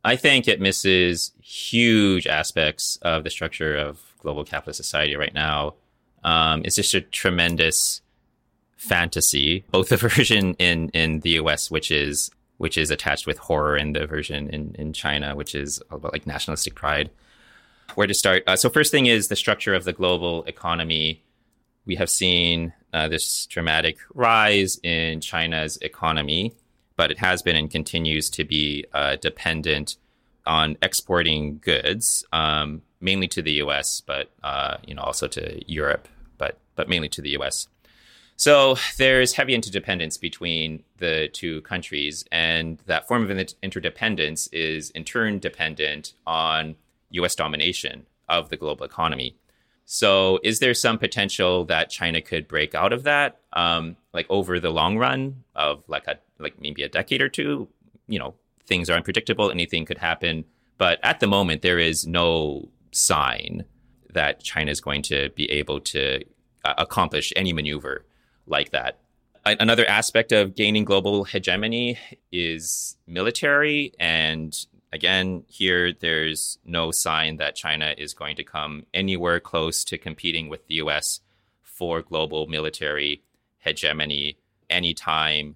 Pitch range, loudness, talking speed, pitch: 75-95 Hz, -22 LUFS, 150 wpm, 80 Hz